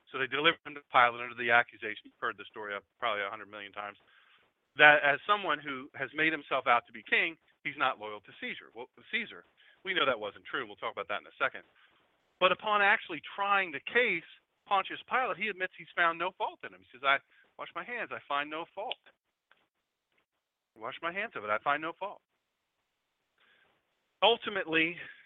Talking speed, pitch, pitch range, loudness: 205 wpm, 155 Hz, 125-190 Hz, -30 LUFS